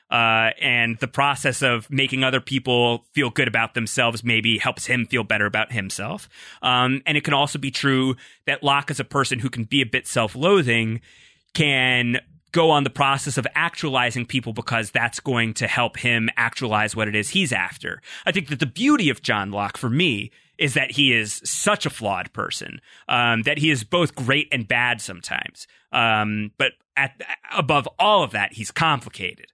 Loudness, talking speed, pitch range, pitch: -21 LUFS, 190 wpm, 115-140 Hz, 125 Hz